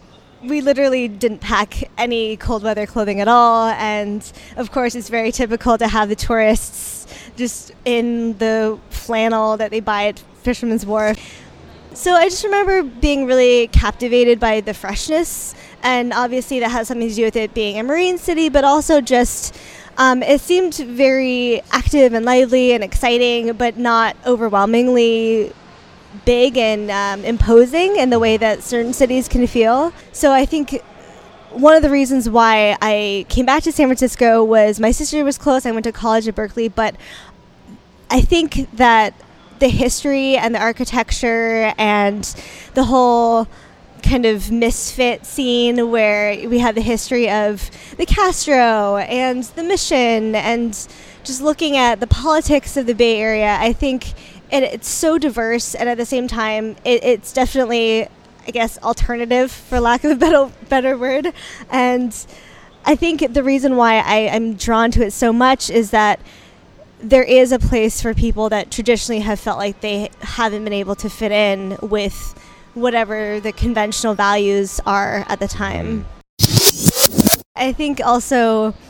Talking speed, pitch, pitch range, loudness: 160 wpm, 235 Hz, 220-255 Hz, -16 LUFS